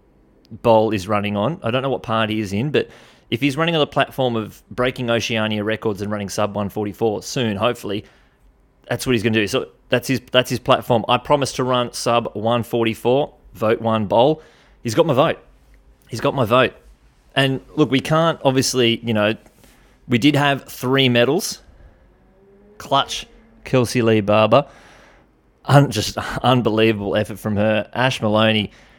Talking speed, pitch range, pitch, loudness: 170 wpm, 105-130 Hz, 115 Hz, -19 LUFS